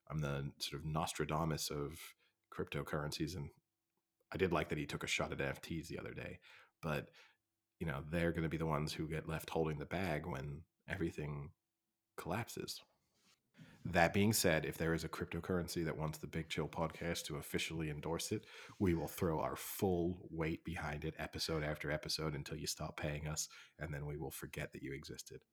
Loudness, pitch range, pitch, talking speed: -41 LUFS, 75-85 Hz, 80 Hz, 190 wpm